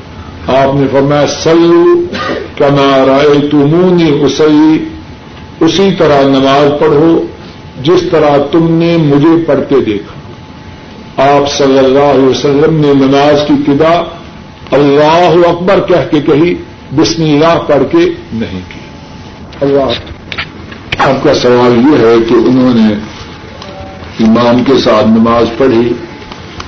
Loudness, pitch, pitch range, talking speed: -8 LUFS, 140 Hz, 120-160 Hz, 115 wpm